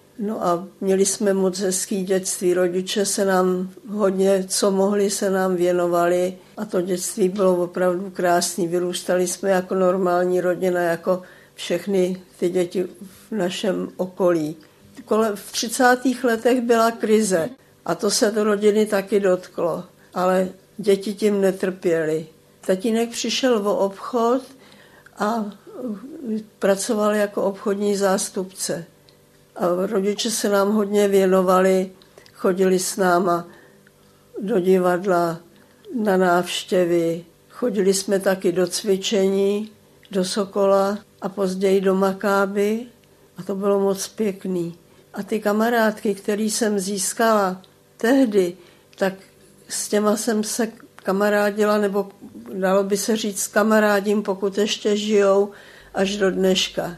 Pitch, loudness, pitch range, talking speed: 195 Hz, -21 LUFS, 185-210 Hz, 120 wpm